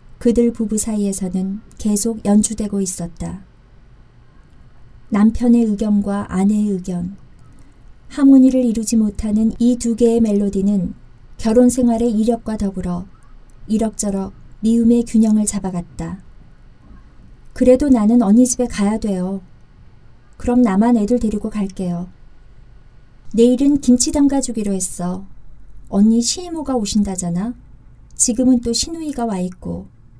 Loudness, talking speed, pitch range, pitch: -17 LUFS, 260 characters per minute, 190-235 Hz, 215 Hz